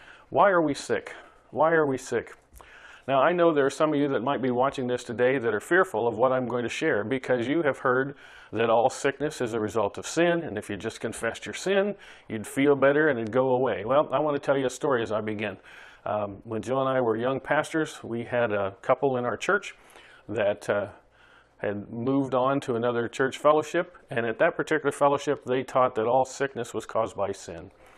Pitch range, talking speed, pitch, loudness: 115-145 Hz, 225 wpm, 130 Hz, -26 LUFS